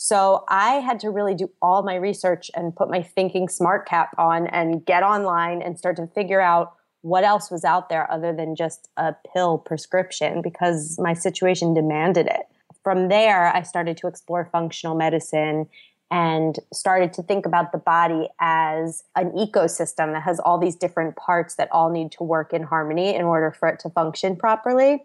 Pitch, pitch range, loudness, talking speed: 175 Hz, 165-185 Hz, -21 LUFS, 185 wpm